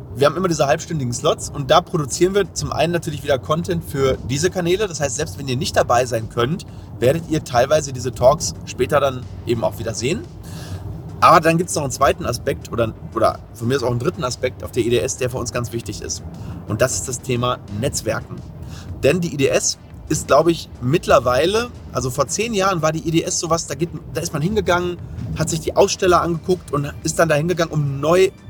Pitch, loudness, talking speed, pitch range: 140 Hz, -19 LUFS, 215 wpm, 120-165 Hz